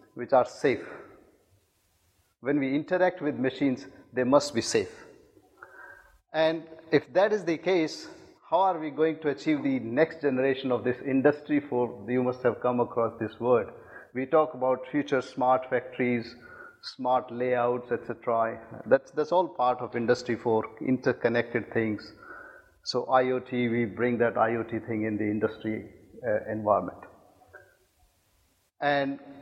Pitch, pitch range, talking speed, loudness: 125 Hz, 115-145 Hz, 140 wpm, -28 LUFS